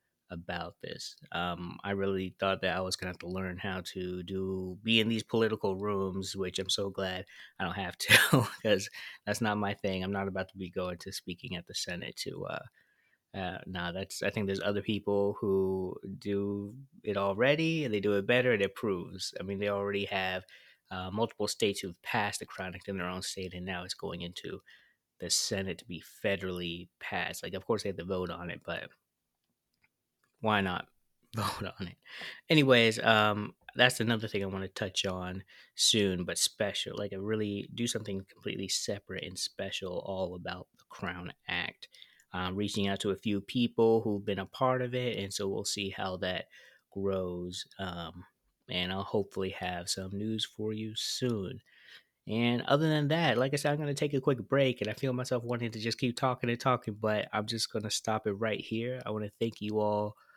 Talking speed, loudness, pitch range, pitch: 205 wpm, -32 LUFS, 95-115 Hz, 100 Hz